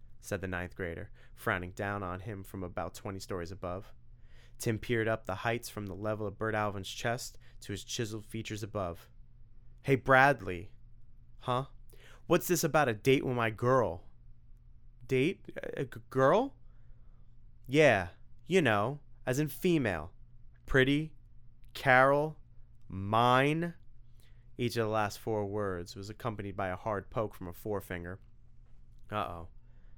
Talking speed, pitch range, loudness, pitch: 140 wpm, 95-120 Hz, -32 LUFS, 115 Hz